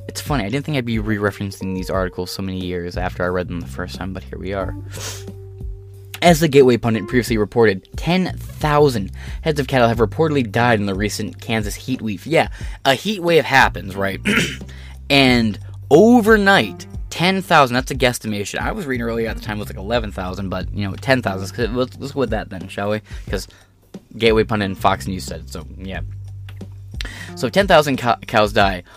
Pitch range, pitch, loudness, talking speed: 95-125 Hz, 105 Hz, -18 LUFS, 200 wpm